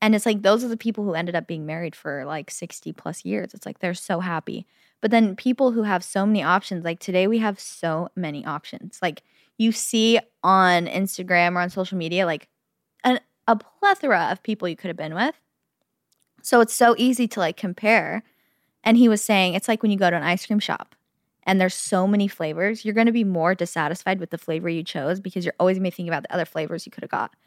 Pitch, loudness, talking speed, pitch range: 190 Hz, -22 LUFS, 240 wpm, 175-225 Hz